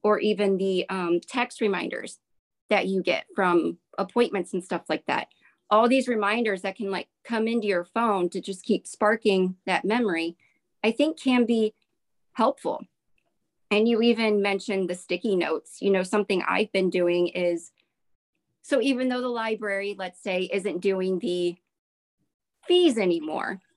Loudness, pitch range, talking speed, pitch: -25 LUFS, 185-225 Hz, 155 wpm, 200 Hz